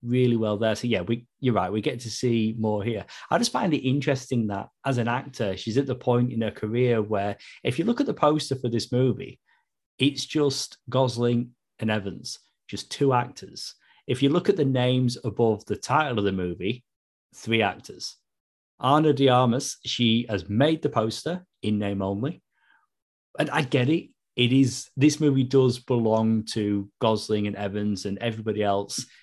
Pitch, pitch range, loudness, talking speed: 120 Hz, 110-135 Hz, -25 LUFS, 185 wpm